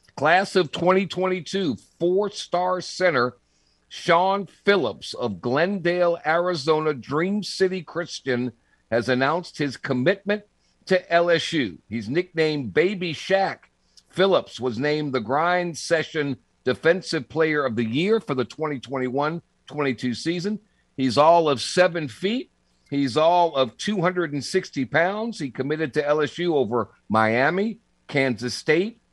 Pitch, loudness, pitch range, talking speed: 160 Hz, -23 LUFS, 135-185 Hz, 120 wpm